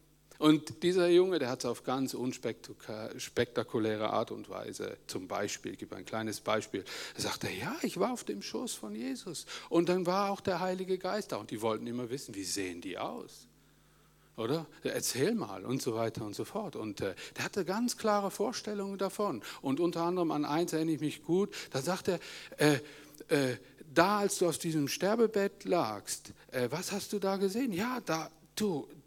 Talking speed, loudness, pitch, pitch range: 190 wpm, -34 LUFS, 165 Hz, 135-195 Hz